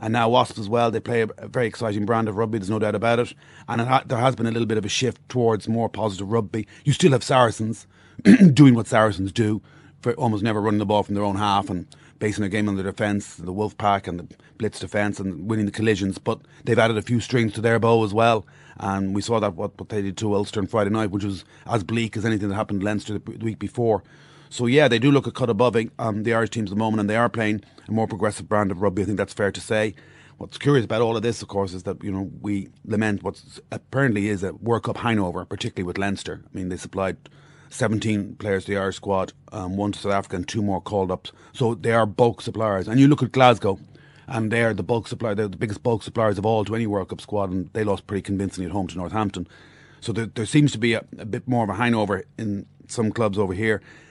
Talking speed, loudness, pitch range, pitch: 265 wpm, -23 LUFS, 100-120 Hz, 110 Hz